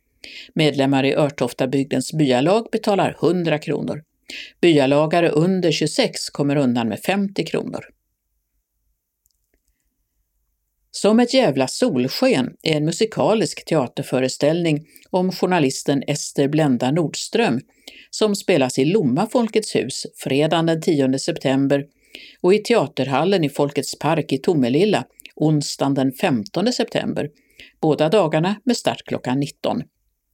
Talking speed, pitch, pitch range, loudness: 110 wpm, 155 Hz, 140-200 Hz, -20 LUFS